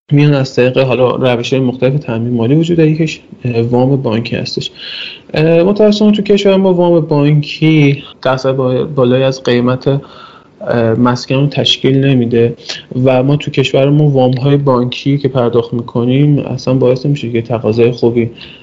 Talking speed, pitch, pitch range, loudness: 140 wpm, 130 Hz, 125-145 Hz, -11 LUFS